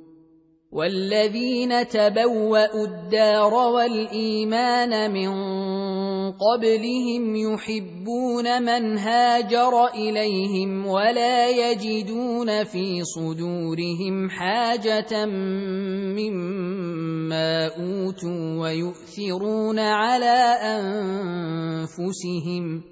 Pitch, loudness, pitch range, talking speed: 210 Hz, -23 LUFS, 180-225 Hz, 50 wpm